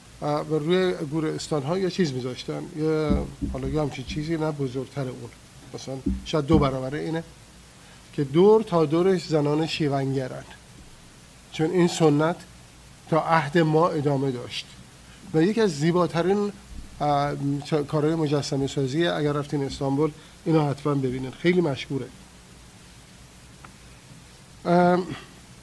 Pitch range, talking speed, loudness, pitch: 130-165 Hz, 110 wpm, -24 LUFS, 150 Hz